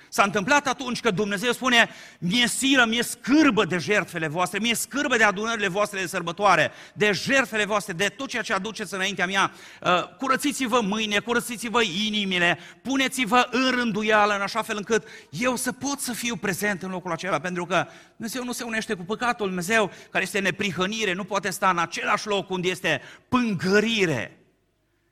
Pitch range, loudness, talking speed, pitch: 190-240 Hz, -23 LUFS, 170 wpm, 210 Hz